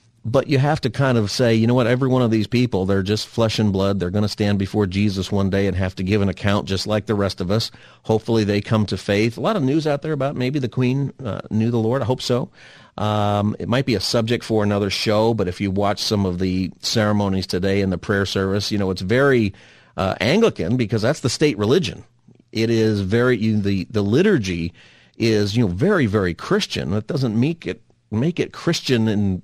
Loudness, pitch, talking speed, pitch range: -20 LUFS, 110 Hz, 235 wpm, 100-125 Hz